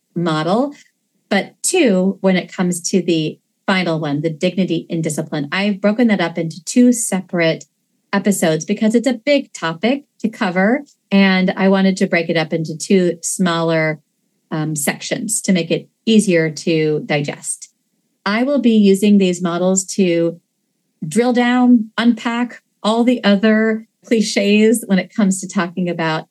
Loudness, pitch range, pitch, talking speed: -16 LUFS, 170-225 Hz, 195 Hz, 155 wpm